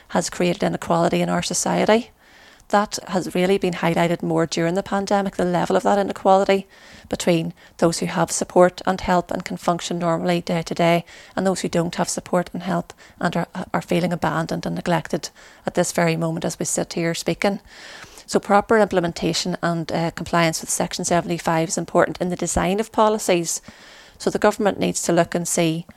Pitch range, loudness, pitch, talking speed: 170-190 Hz, -21 LUFS, 175 Hz, 190 wpm